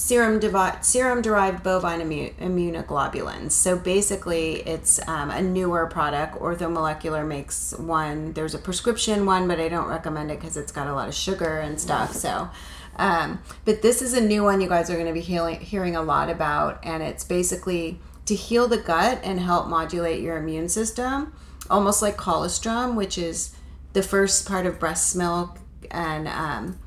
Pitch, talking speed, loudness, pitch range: 175 Hz, 180 wpm, -24 LUFS, 160-195 Hz